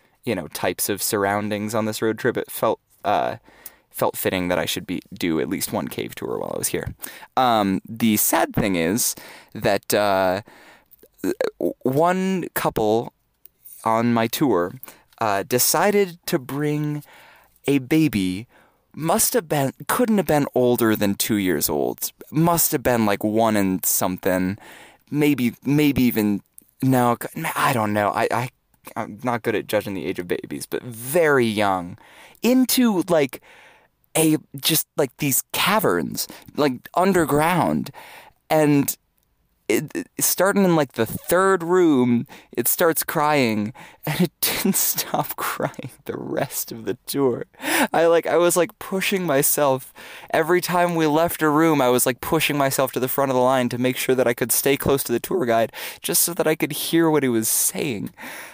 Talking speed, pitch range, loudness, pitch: 165 wpm, 115-165 Hz, -21 LUFS, 140 Hz